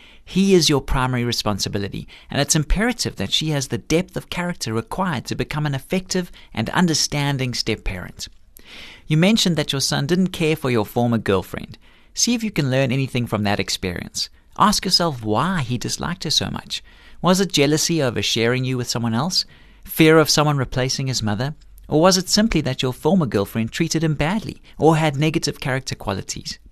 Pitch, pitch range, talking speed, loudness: 145 Hz, 120-165 Hz, 185 wpm, -20 LUFS